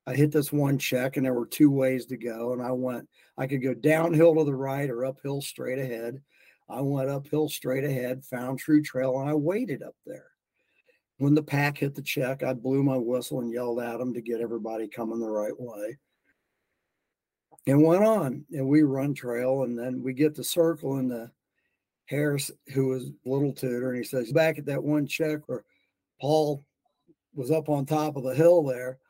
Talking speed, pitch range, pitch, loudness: 200 wpm, 125-150 Hz, 135 Hz, -27 LUFS